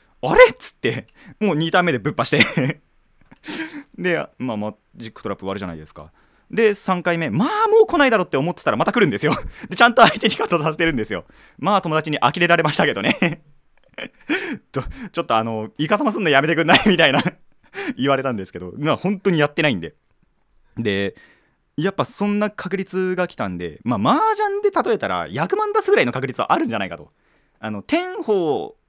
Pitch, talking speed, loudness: 185 Hz, 405 characters per minute, -19 LUFS